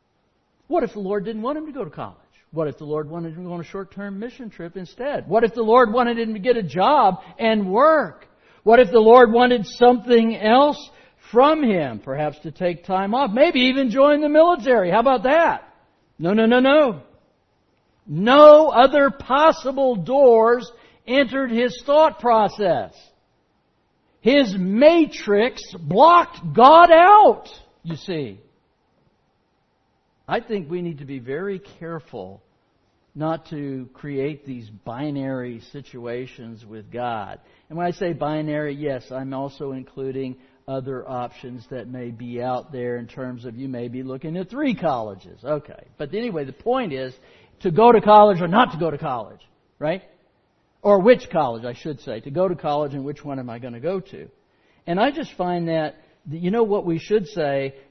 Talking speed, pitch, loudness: 175 wpm, 180 Hz, -18 LUFS